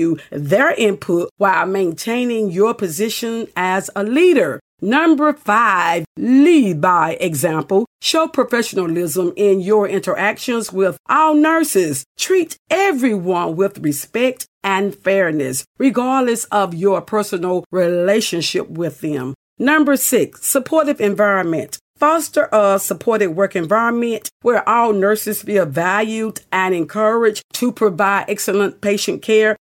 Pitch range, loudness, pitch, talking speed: 185-235 Hz, -16 LUFS, 205 Hz, 115 wpm